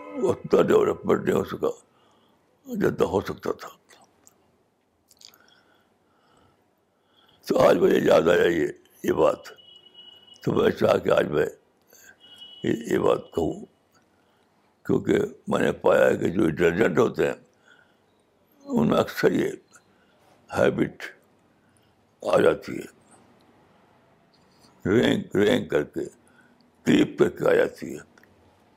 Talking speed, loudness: 110 wpm, -23 LUFS